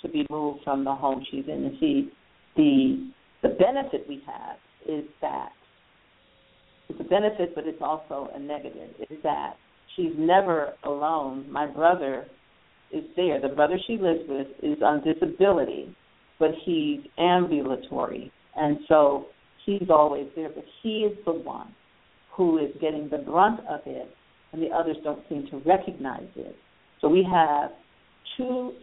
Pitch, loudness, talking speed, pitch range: 160 Hz, -26 LUFS, 155 wpm, 150-225 Hz